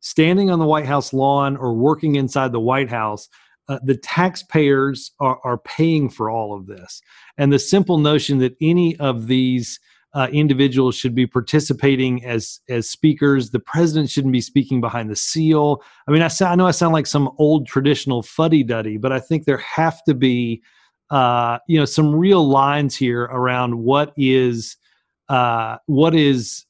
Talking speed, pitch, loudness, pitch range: 180 wpm, 135 Hz, -18 LUFS, 125-155 Hz